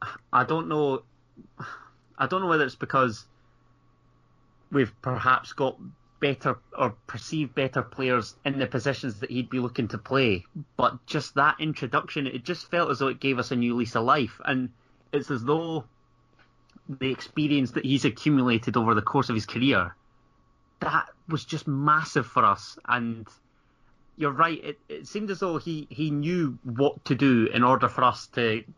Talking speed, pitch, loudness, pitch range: 175 wpm, 135 Hz, -26 LUFS, 125-150 Hz